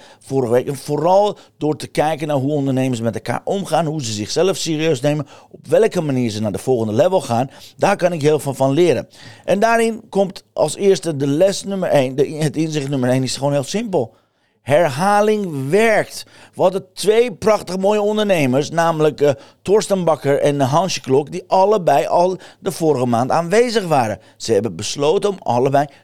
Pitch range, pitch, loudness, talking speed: 140-195 Hz, 155 Hz, -17 LUFS, 185 wpm